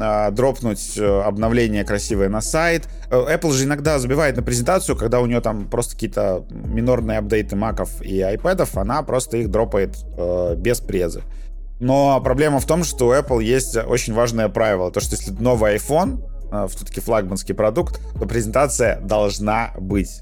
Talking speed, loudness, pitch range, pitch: 150 wpm, -20 LUFS, 105-125 Hz, 110 Hz